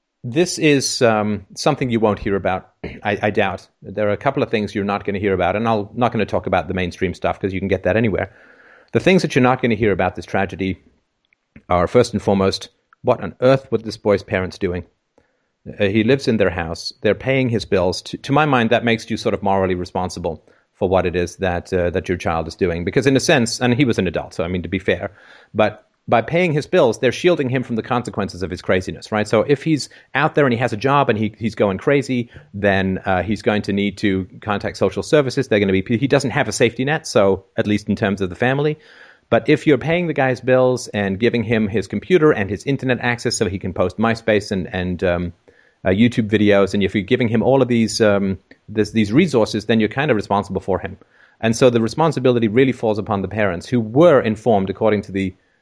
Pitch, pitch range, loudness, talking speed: 110 Hz, 95-125 Hz, -18 LUFS, 255 wpm